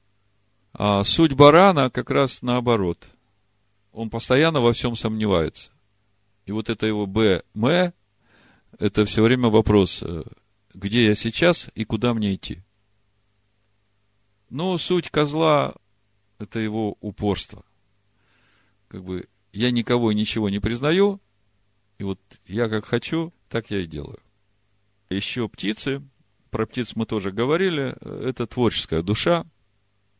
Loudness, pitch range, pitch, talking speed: -22 LUFS, 100-120 Hz, 105 Hz, 120 wpm